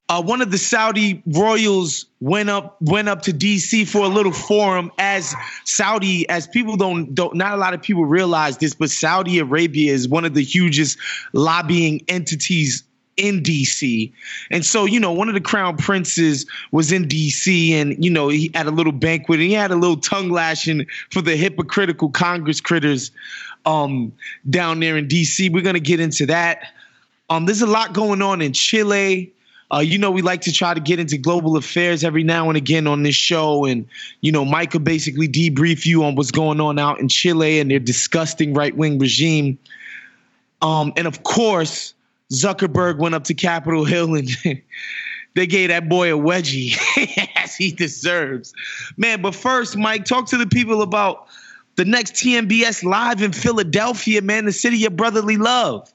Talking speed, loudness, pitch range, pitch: 185 wpm, -18 LUFS, 155-200 Hz, 170 Hz